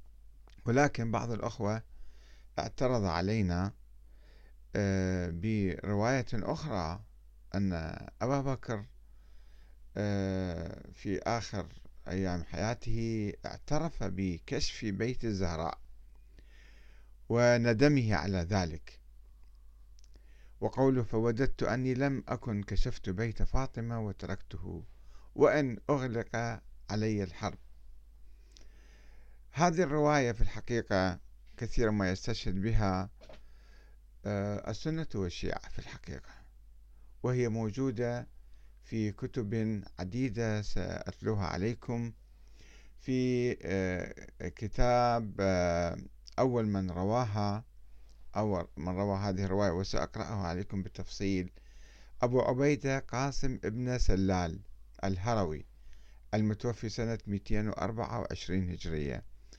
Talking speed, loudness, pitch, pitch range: 75 wpm, -33 LUFS, 100 Hz, 80-115 Hz